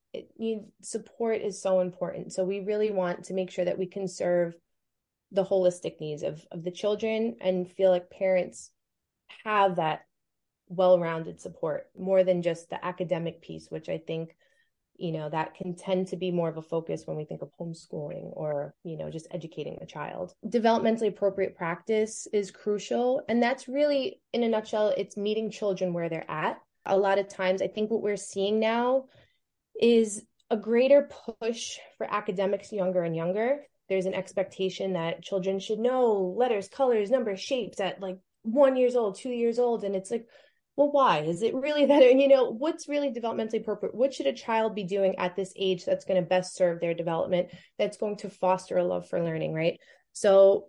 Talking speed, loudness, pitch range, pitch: 190 wpm, -28 LUFS, 180-225 Hz, 195 Hz